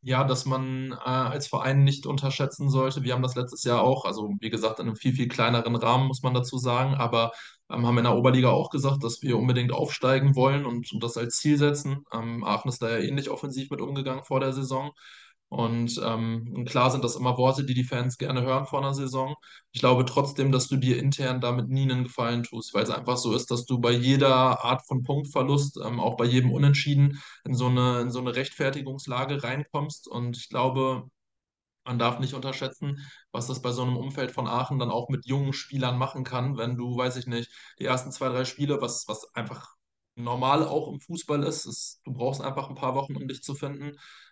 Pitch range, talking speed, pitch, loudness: 125-135 Hz, 220 wpm, 130 Hz, -27 LUFS